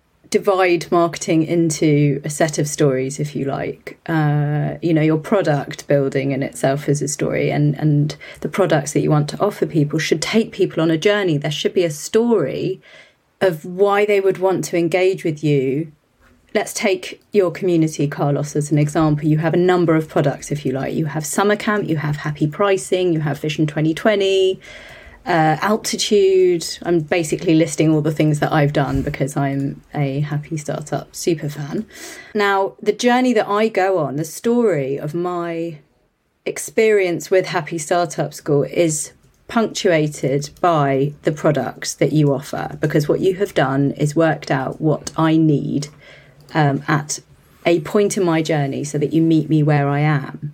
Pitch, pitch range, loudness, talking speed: 160 Hz, 145-185 Hz, -18 LUFS, 175 wpm